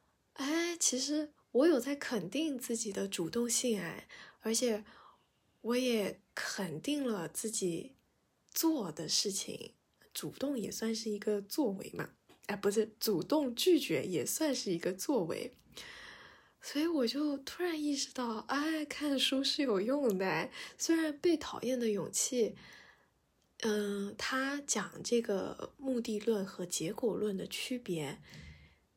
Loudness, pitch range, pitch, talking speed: -35 LUFS, 205-285 Hz, 235 Hz, 190 characters per minute